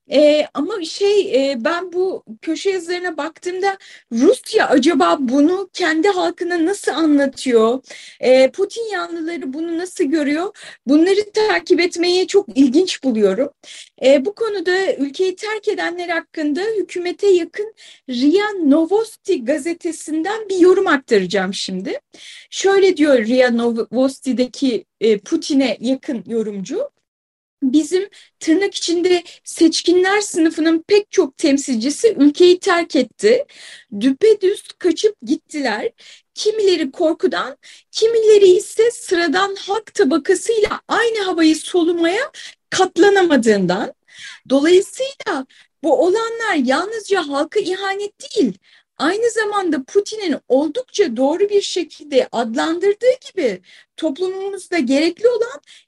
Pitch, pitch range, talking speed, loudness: 345 Hz, 290-395 Hz, 105 wpm, -17 LUFS